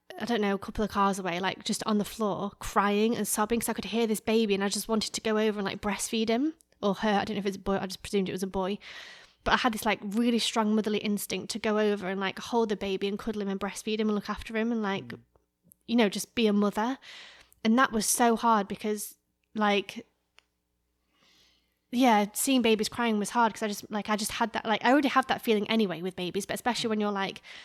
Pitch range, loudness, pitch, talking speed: 200-225 Hz, -28 LUFS, 215 Hz, 260 wpm